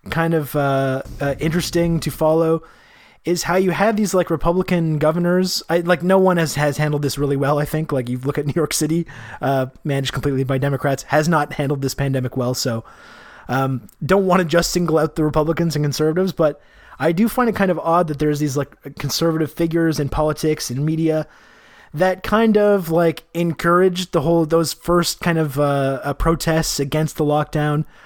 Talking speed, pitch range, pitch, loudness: 195 wpm, 145-170 Hz, 155 Hz, -19 LUFS